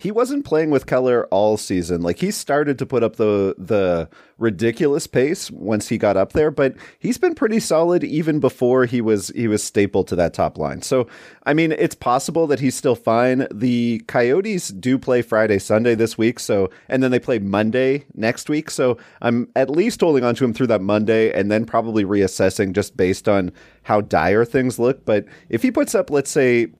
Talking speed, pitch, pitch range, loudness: 205 wpm, 120 Hz, 105-140 Hz, -19 LUFS